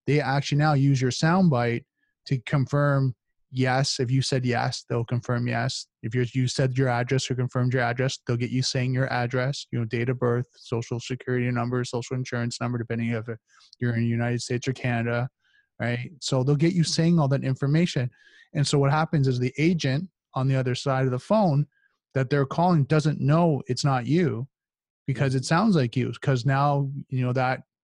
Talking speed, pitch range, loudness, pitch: 200 wpm, 125-145 Hz, -25 LUFS, 130 Hz